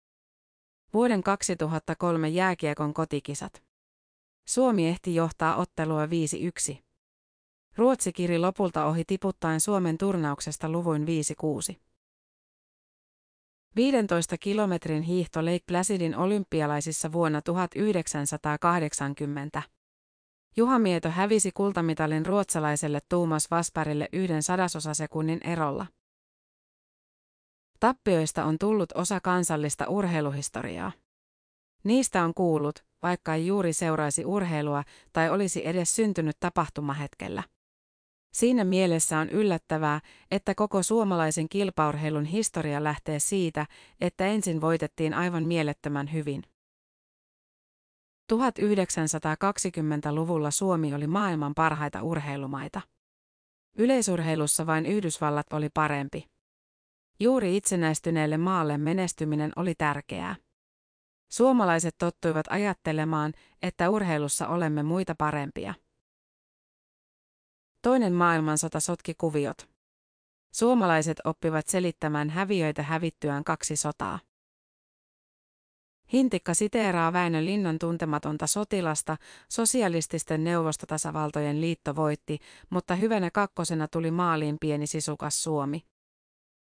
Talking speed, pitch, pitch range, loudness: 85 wpm, 165 Hz, 150-185 Hz, -27 LUFS